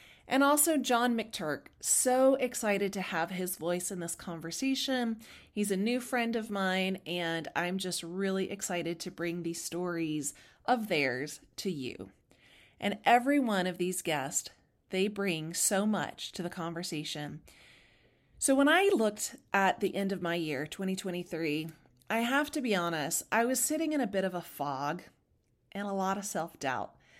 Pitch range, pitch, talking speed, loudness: 170-230 Hz, 190 Hz, 170 wpm, -31 LUFS